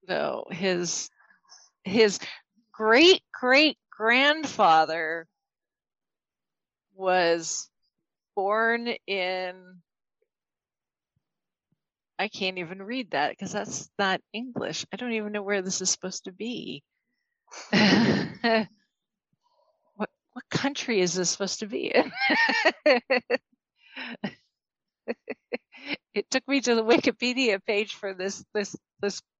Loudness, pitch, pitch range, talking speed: -25 LUFS, 215 Hz, 190-250 Hz, 100 wpm